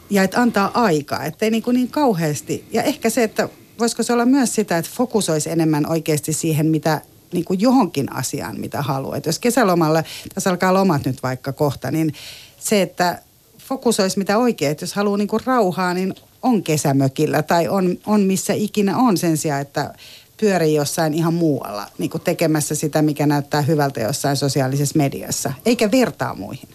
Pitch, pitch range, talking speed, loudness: 165 Hz, 150-215 Hz, 175 wpm, -19 LUFS